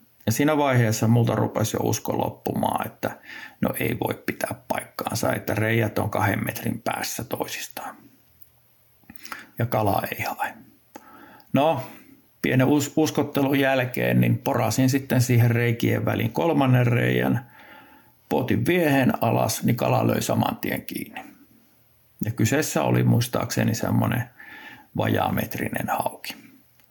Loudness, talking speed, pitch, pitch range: -23 LUFS, 120 wpm, 115 Hz, 105-130 Hz